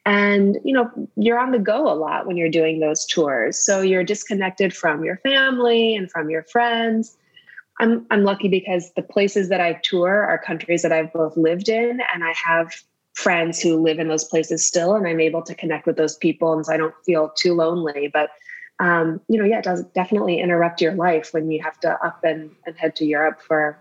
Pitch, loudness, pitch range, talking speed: 170 Hz, -20 LUFS, 160-205 Hz, 220 wpm